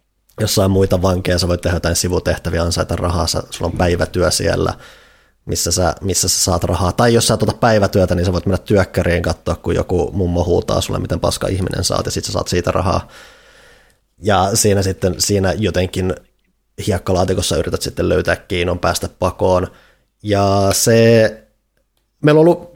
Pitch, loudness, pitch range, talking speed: 95 Hz, -16 LUFS, 90-105 Hz, 170 wpm